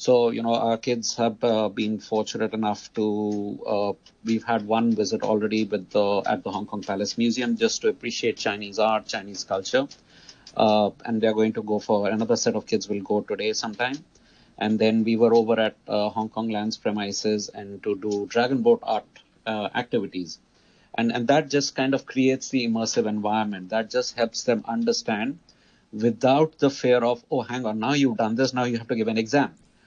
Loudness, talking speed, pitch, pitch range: -24 LUFS, 200 wpm, 110 Hz, 105-120 Hz